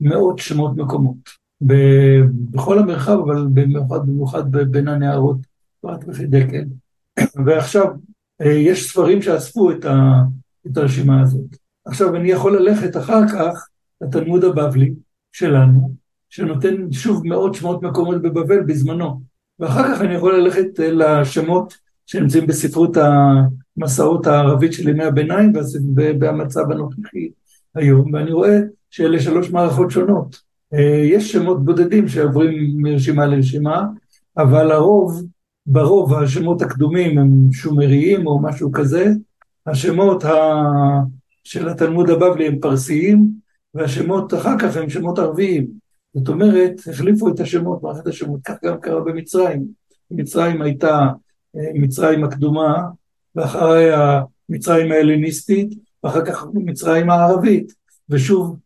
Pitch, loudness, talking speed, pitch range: 155 Hz, -16 LUFS, 115 wpm, 145-180 Hz